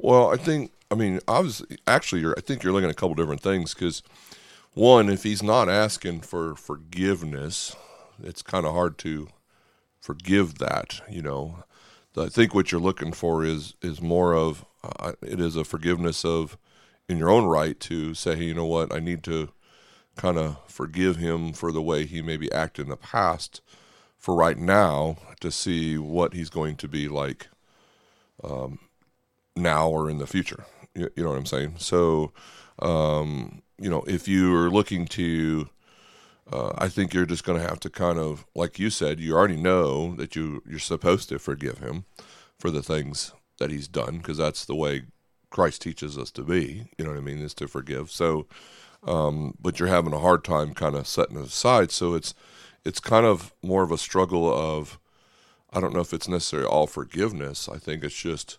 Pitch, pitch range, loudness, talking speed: 80 Hz, 75-90 Hz, -25 LUFS, 195 wpm